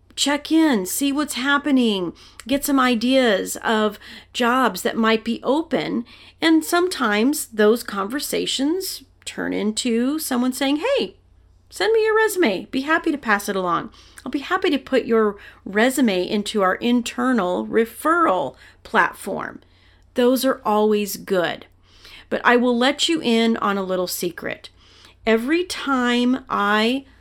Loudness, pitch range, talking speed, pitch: -20 LUFS, 215-285 Hz, 135 wpm, 245 Hz